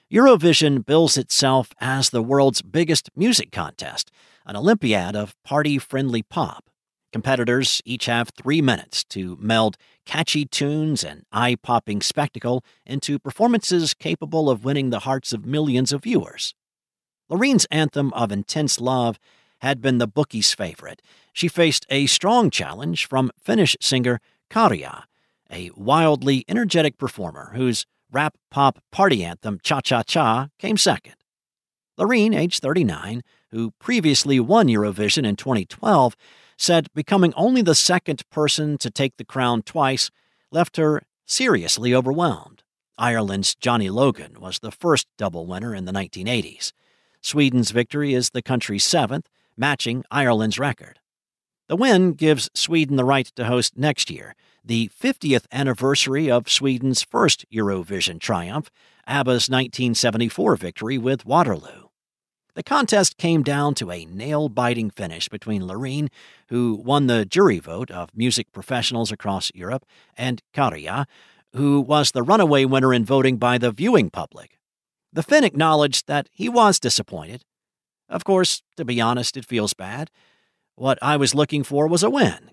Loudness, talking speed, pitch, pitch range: -20 LUFS, 140 wpm, 130 Hz, 115-150 Hz